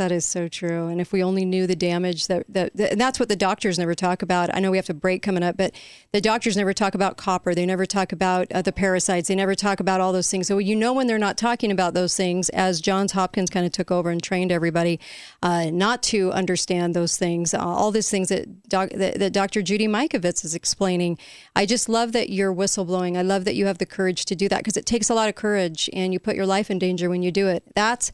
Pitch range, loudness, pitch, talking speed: 180-200 Hz, -22 LUFS, 190 Hz, 265 wpm